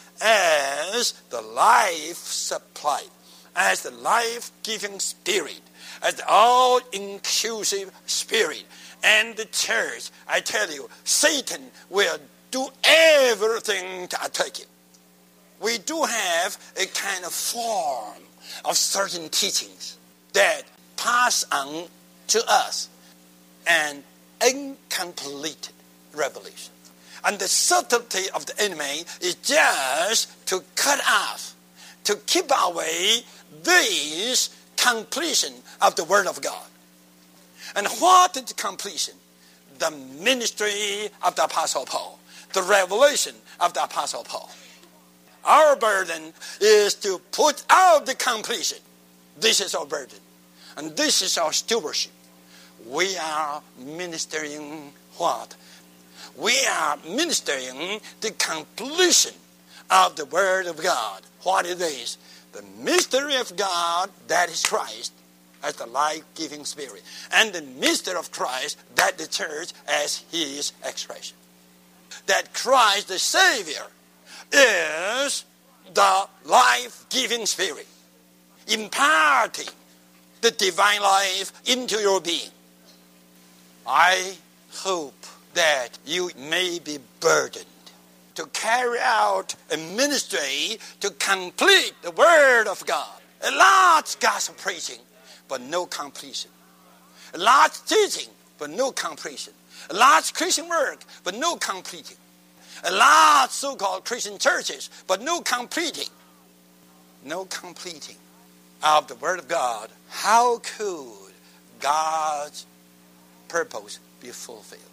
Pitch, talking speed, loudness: 165 Hz, 110 wpm, -22 LUFS